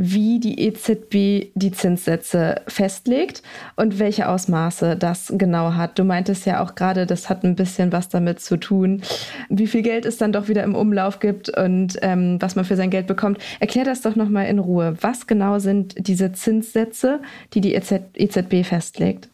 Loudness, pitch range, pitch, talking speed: -20 LUFS, 185-215 Hz, 195 Hz, 180 wpm